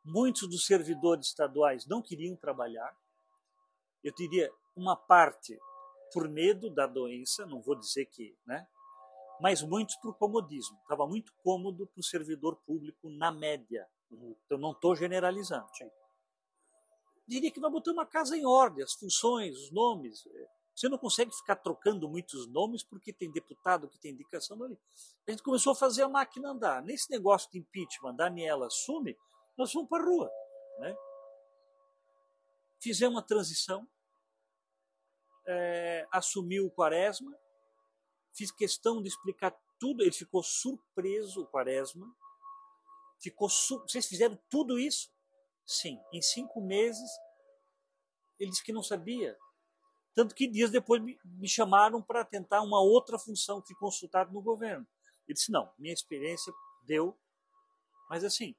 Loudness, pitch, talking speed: -32 LUFS, 190 Hz, 145 wpm